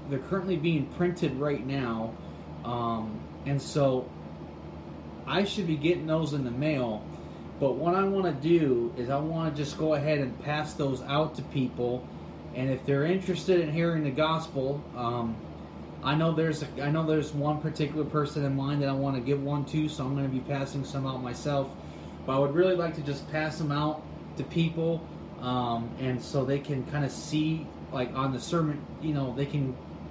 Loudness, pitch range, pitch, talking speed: -30 LUFS, 130-155 Hz, 140 Hz, 200 wpm